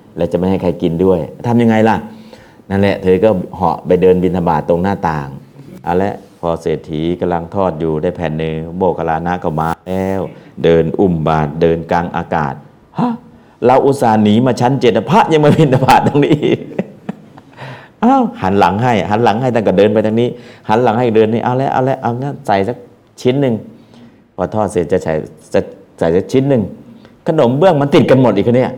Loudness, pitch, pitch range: -14 LUFS, 100 Hz, 85-120 Hz